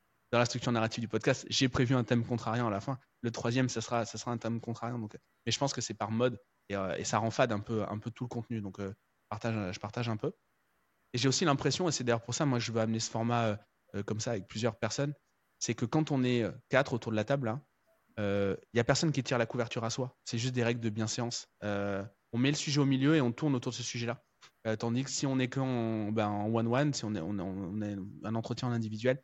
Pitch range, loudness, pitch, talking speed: 110-130 Hz, -33 LUFS, 120 Hz, 275 wpm